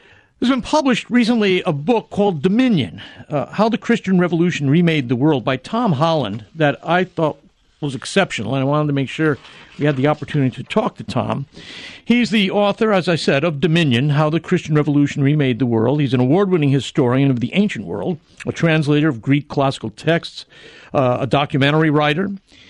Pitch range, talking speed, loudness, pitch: 140-190 Hz, 190 wpm, -18 LUFS, 155 Hz